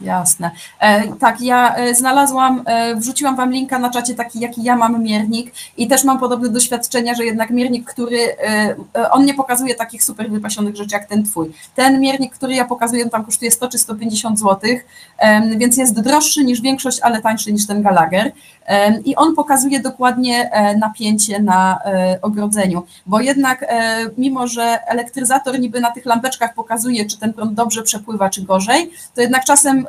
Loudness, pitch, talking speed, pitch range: -15 LUFS, 235 Hz, 165 wpm, 215-255 Hz